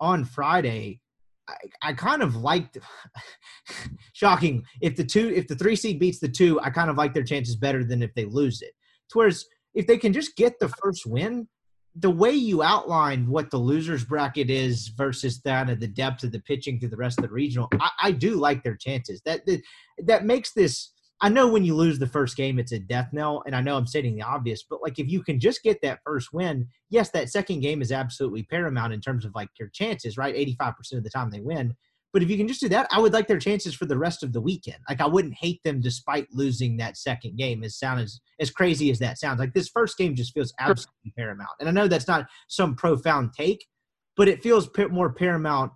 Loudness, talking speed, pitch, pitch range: -25 LUFS, 235 wpm, 145 Hz, 125-185 Hz